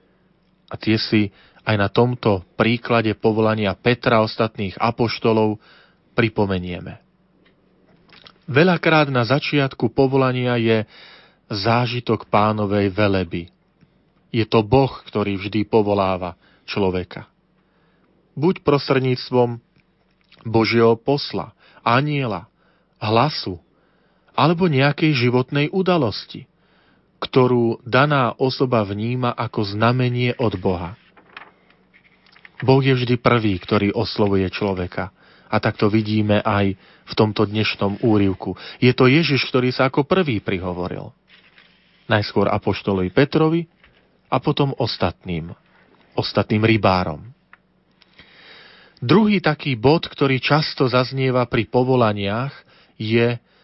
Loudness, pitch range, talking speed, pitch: -19 LUFS, 105-135 Hz, 95 wpm, 115 Hz